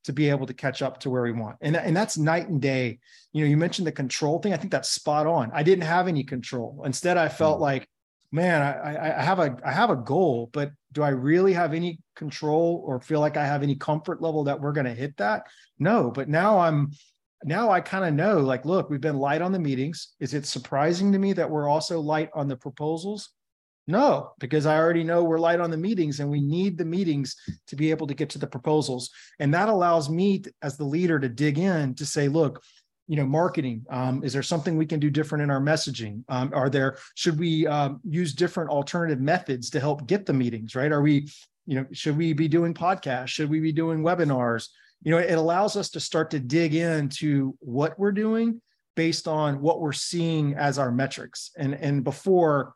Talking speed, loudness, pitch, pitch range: 225 wpm, -25 LUFS, 150 Hz, 140-170 Hz